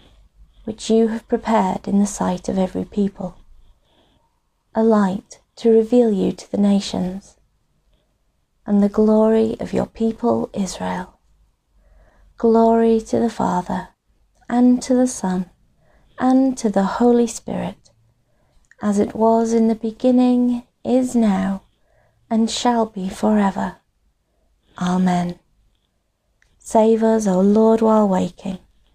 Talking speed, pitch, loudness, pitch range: 120 wpm, 215 Hz, -18 LUFS, 185-230 Hz